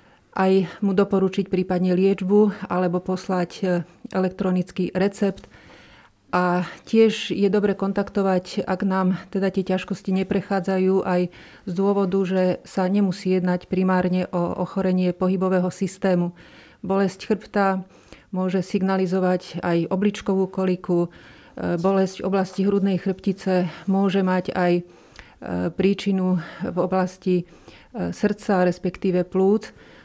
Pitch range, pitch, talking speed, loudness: 180-195 Hz, 190 Hz, 105 wpm, -23 LUFS